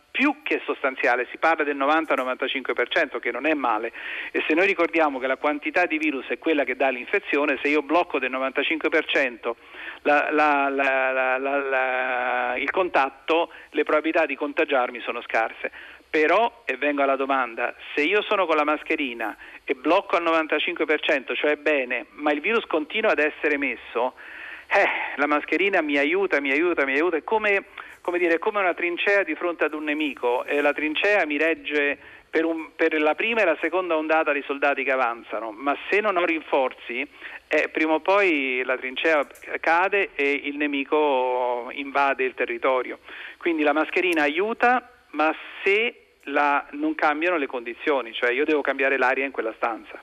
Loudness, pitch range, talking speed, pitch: -23 LUFS, 140-175 Hz, 175 wpm, 150 Hz